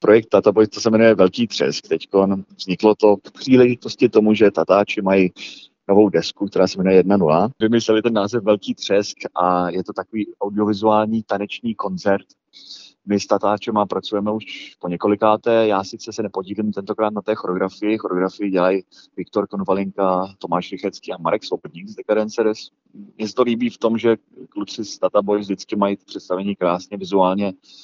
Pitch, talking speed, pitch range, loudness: 100 Hz, 165 wpm, 95-110 Hz, -19 LUFS